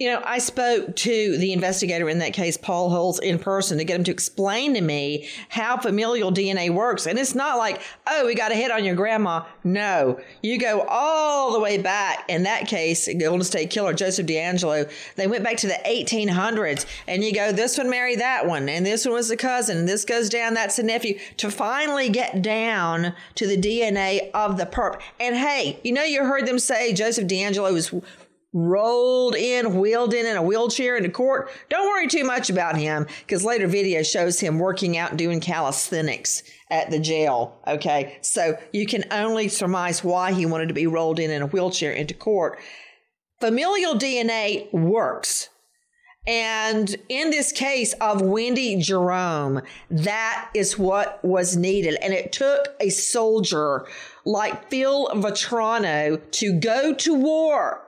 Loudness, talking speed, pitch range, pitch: -22 LUFS, 180 wpm, 175-235 Hz, 205 Hz